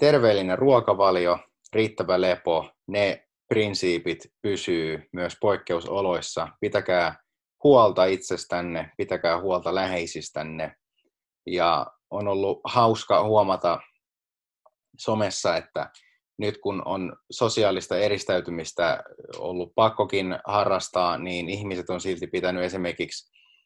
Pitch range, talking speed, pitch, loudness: 85-100 Hz, 90 wpm, 90 Hz, -25 LUFS